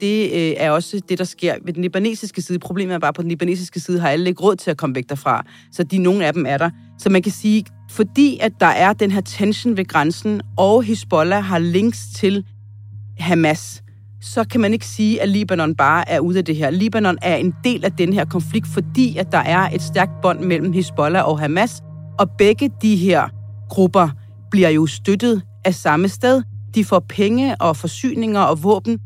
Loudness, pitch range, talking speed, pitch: -18 LUFS, 155-200 Hz, 215 wpm, 180 Hz